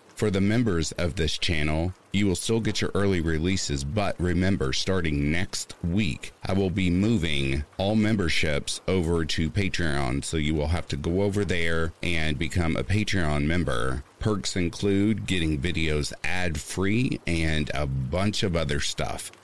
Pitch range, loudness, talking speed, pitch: 80-100 Hz, -26 LUFS, 160 wpm, 90 Hz